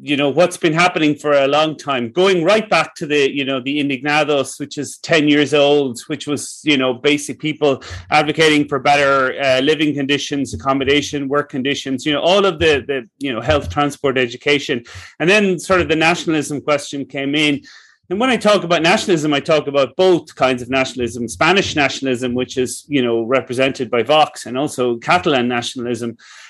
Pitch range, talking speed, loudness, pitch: 135-155 Hz, 190 wpm, -16 LUFS, 145 Hz